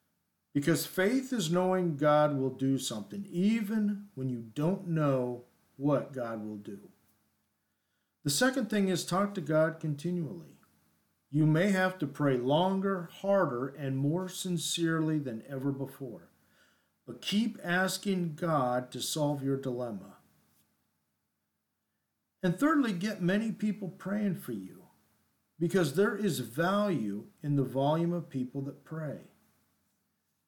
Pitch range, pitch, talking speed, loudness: 135-190 Hz, 165 Hz, 130 wpm, -31 LUFS